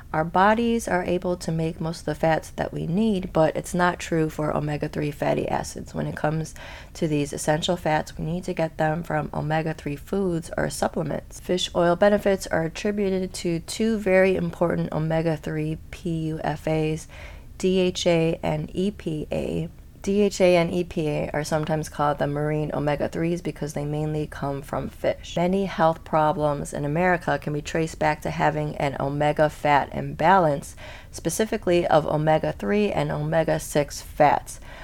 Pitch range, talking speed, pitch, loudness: 150-180 Hz, 160 wpm, 160 Hz, -24 LUFS